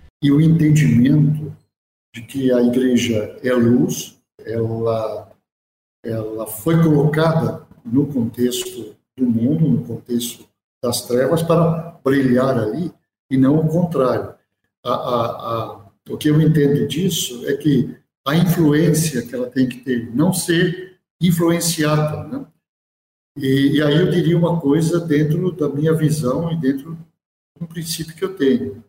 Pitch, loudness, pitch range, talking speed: 145 Hz, -18 LUFS, 120-165 Hz, 140 wpm